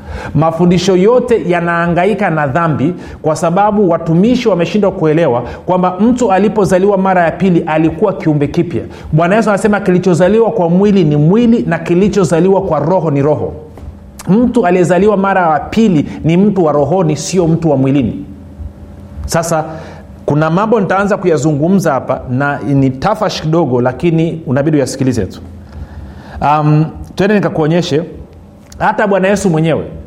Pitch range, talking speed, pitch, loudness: 145-190 Hz, 135 wpm, 170 Hz, -12 LUFS